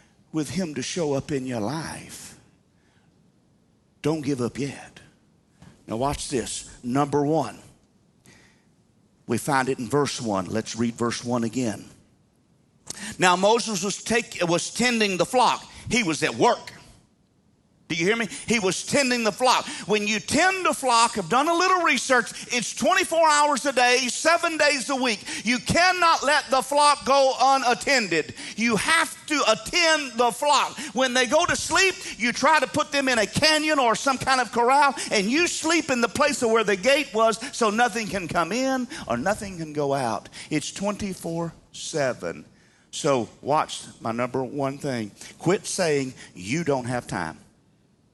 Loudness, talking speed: -23 LUFS, 165 wpm